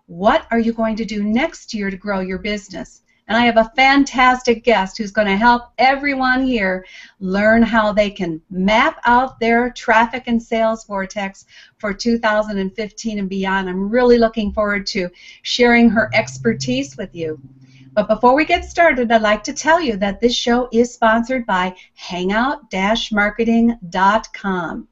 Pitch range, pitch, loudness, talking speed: 195-240 Hz, 220 Hz, -17 LUFS, 160 wpm